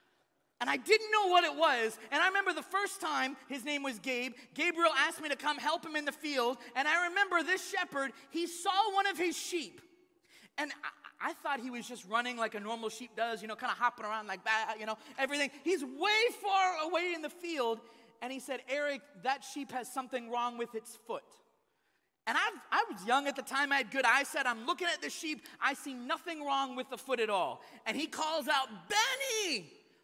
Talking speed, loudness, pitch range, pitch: 225 wpm, -33 LUFS, 245-345 Hz, 280 Hz